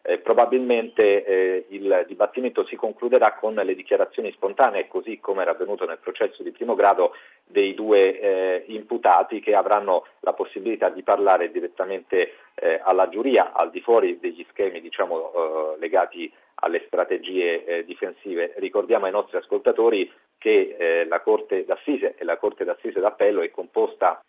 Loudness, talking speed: -22 LUFS, 155 wpm